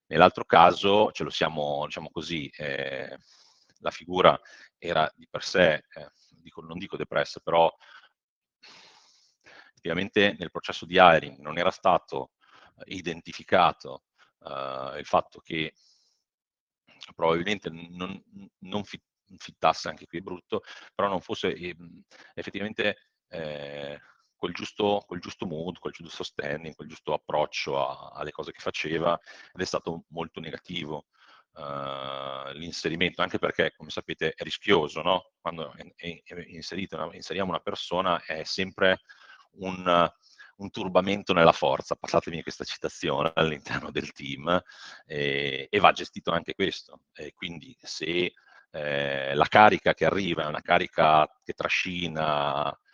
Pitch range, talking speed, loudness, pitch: 70-90 Hz, 130 wpm, -27 LUFS, 80 Hz